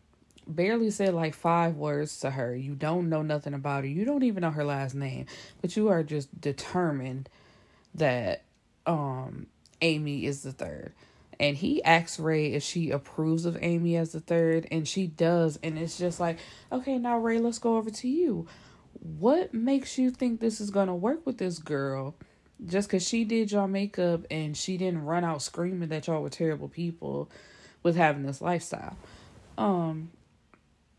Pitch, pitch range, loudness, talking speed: 165 Hz, 150-195 Hz, -29 LUFS, 175 wpm